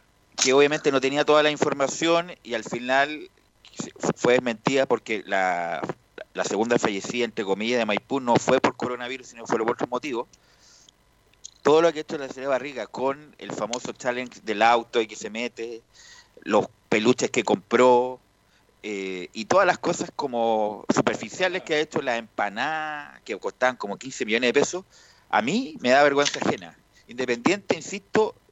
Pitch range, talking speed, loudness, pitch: 115-150 Hz, 170 wpm, -24 LUFS, 125 Hz